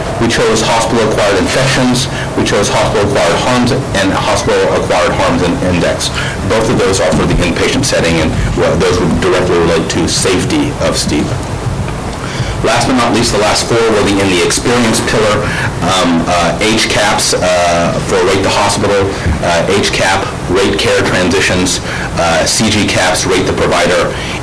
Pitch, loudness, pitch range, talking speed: 100 Hz, -11 LUFS, 90-120 Hz, 155 wpm